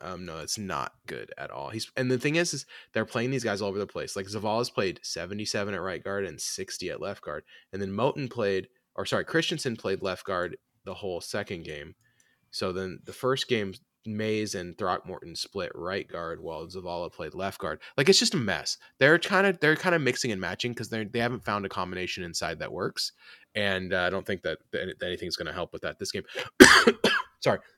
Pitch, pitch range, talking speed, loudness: 110 Hz, 100-130 Hz, 220 wpm, -28 LUFS